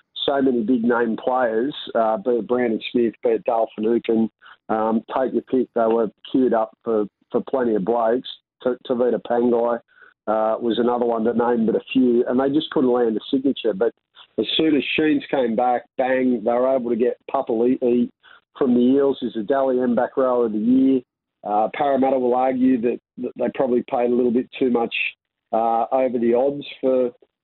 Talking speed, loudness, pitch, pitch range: 195 wpm, -21 LUFS, 120 Hz, 115-130 Hz